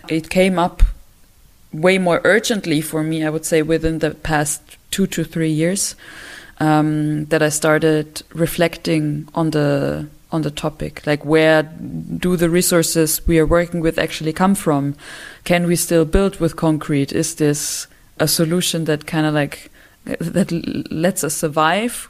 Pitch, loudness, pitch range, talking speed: 160 Hz, -18 LUFS, 155-170 Hz, 160 wpm